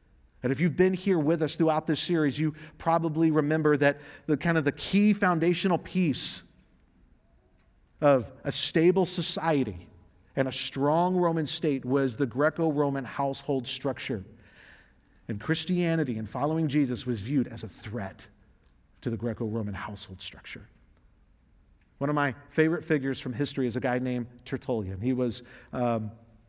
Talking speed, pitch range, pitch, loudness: 145 wpm, 115-160 Hz, 140 Hz, -28 LUFS